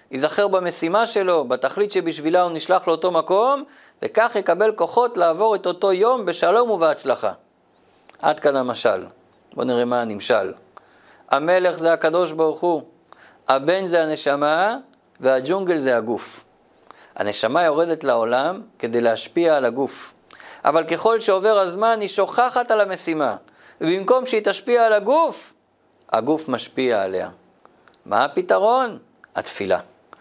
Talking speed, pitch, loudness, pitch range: 125 wpm, 180 Hz, -20 LUFS, 160-205 Hz